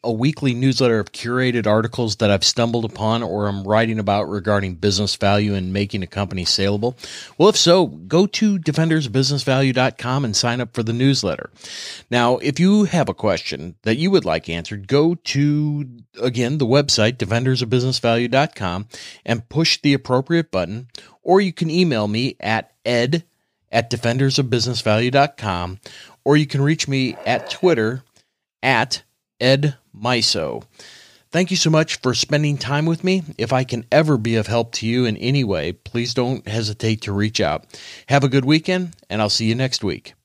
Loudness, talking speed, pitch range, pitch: -19 LUFS, 165 wpm, 110-145 Hz, 125 Hz